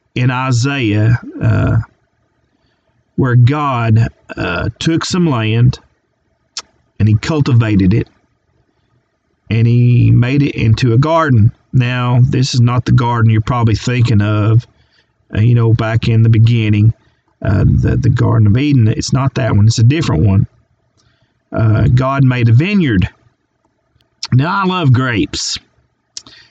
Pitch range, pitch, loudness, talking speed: 110-130 Hz, 120 Hz, -13 LUFS, 135 wpm